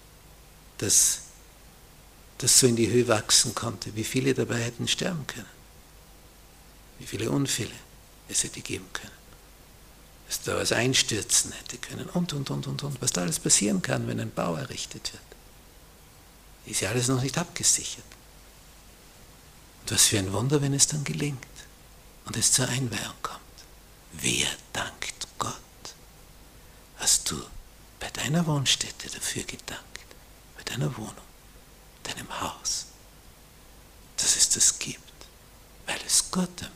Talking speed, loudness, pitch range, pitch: 135 wpm, -25 LUFS, 95-135 Hz, 120 Hz